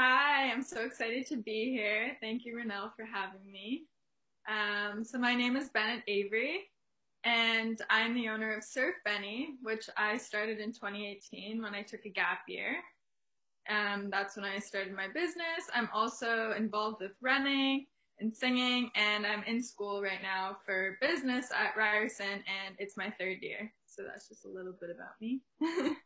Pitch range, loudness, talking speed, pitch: 205-250 Hz, -34 LUFS, 175 wpm, 220 Hz